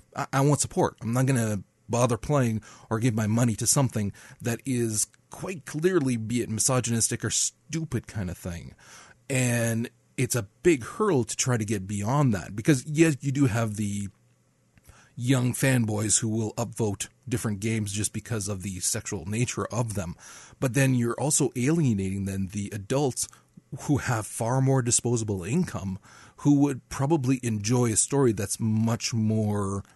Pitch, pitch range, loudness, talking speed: 120 Hz, 105-135 Hz, -26 LUFS, 165 wpm